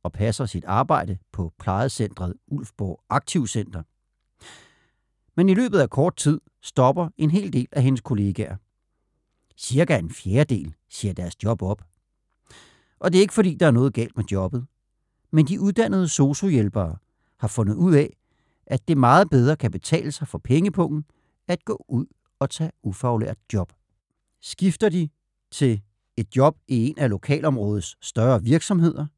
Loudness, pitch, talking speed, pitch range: -22 LUFS, 130 Hz, 150 wpm, 105-155 Hz